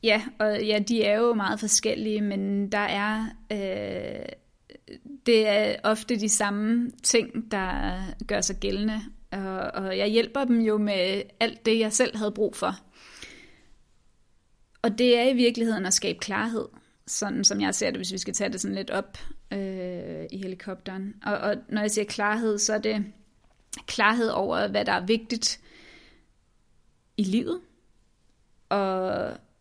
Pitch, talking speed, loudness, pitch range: 215 Hz, 160 wpm, -26 LUFS, 200-225 Hz